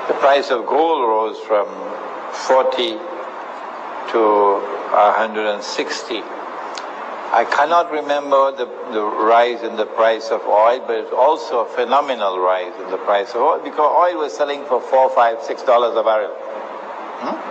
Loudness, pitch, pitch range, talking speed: -18 LUFS, 120 Hz, 110-145 Hz, 145 wpm